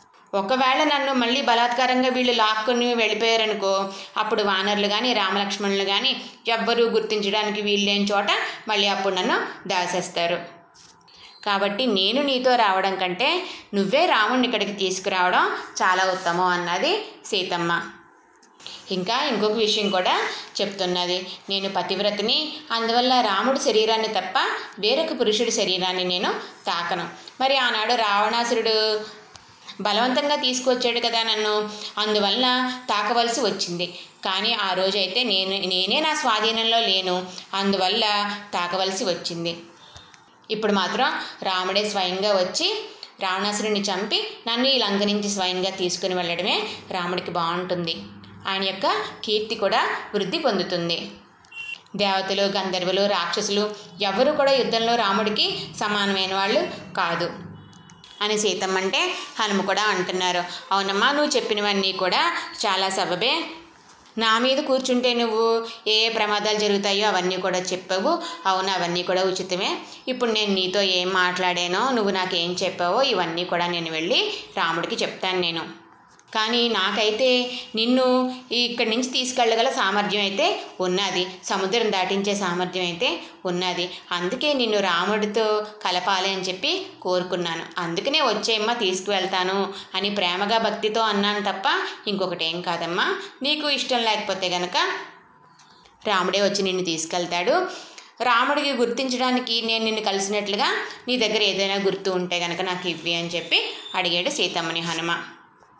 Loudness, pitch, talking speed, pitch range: -22 LUFS, 205 Hz, 115 wpm, 185-235 Hz